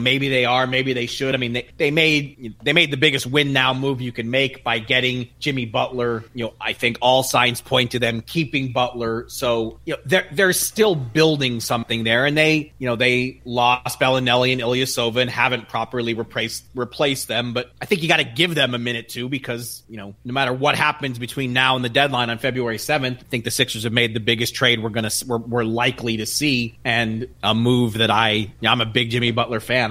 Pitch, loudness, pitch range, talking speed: 125 Hz, -20 LUFS, 120-135 Hz, 230 wpm